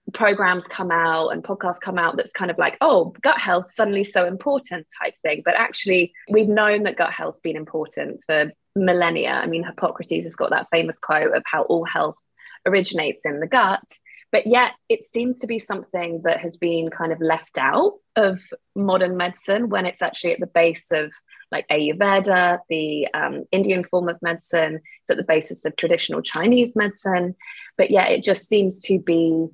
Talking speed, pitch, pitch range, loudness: 190 wpm, 180 Hz, 165-200 Hz, -21 LUFS